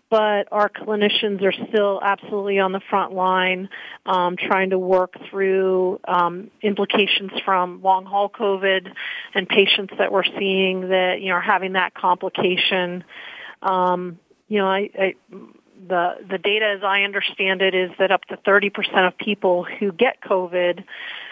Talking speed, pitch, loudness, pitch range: 160 wpm, 190 Hz, -20 LUFS, 185-200 Hz